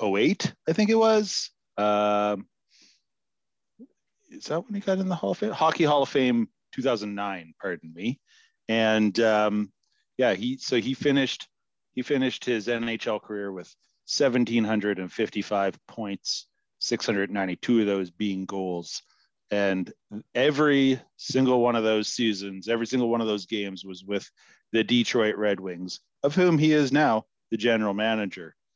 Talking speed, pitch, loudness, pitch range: 145 wpm, 110 Hz, -26 LUFS, 100-135 Hz